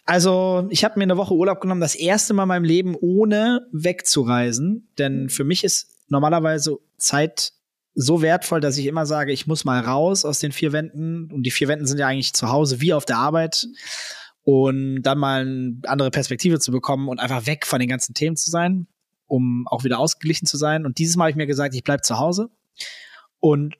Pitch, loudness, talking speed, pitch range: 155 Hz, -20 LUFS, 210 wpm, 135-175 Hz